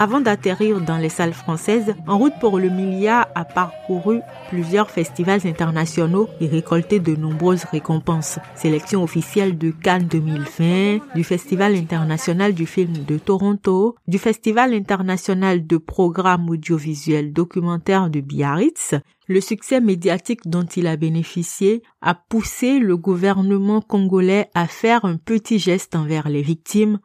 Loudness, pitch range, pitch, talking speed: -19 LUFS, 165-205 Hz, 185 Hz, 140 wpm